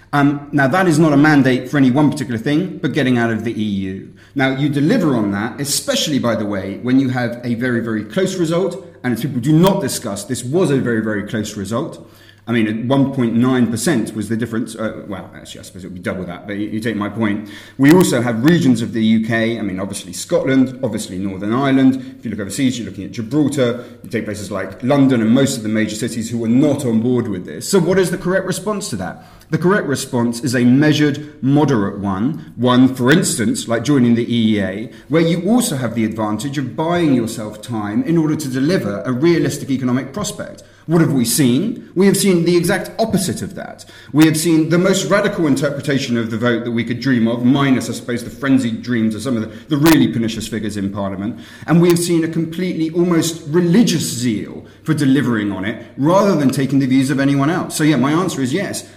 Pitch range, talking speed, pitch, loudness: 110-150 Hz, 225 wpm, 125 Hz, -17 LUFS